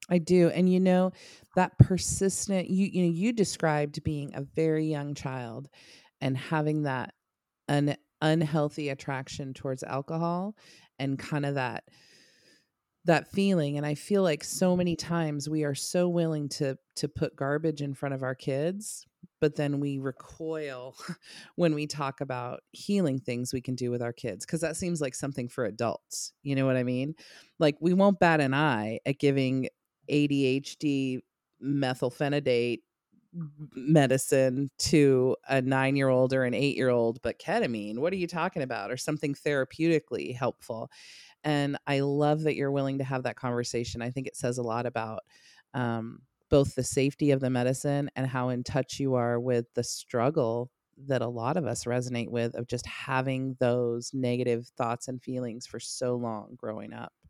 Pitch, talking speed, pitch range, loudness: 140 Hz, 175 wpm, 125-155 Hz, -29 LUFS